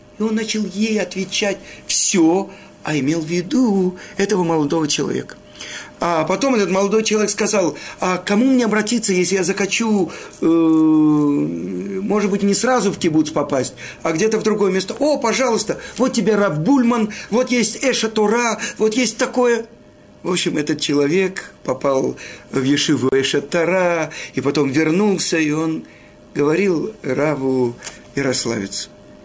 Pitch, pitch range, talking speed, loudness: 190 Hz, 155-215 Hz, 135 wpm, -18 LUFS